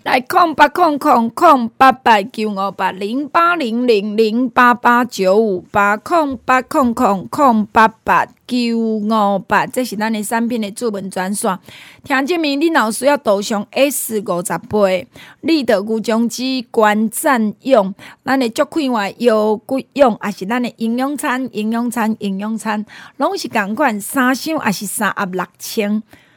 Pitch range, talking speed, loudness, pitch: 210-265 Hz, 220 characters per minute, -16 LUFS, 230 Hz